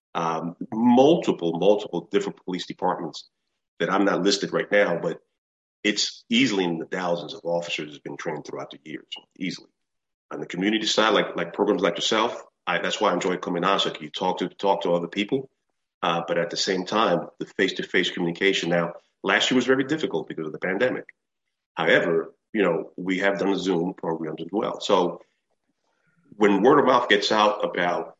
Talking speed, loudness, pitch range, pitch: 190 wpm, -24 LUFS, 85-105 Hz, 90 Hz